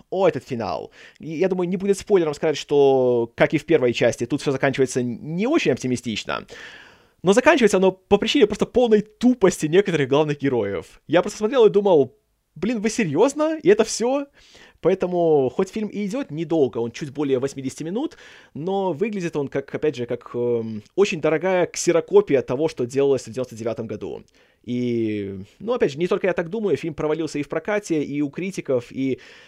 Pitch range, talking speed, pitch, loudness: 135-200 Hz, 180 wpm, 160 Hz, -21 LUFS